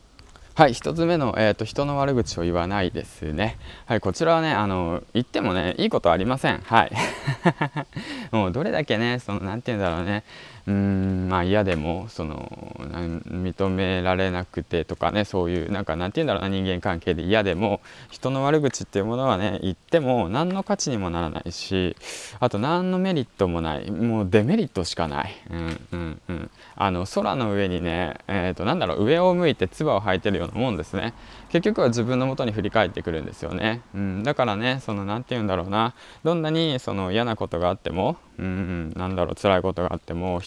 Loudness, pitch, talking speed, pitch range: -24 LUFS, 100 Hz, 405 characters per minute, 90-120 Hz